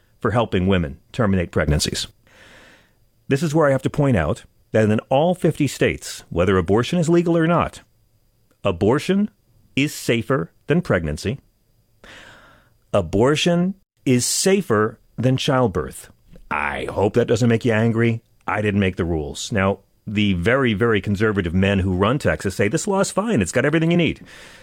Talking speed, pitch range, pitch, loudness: 160 wpm, 100-135 Hz, 115 Hz, -20 LUFS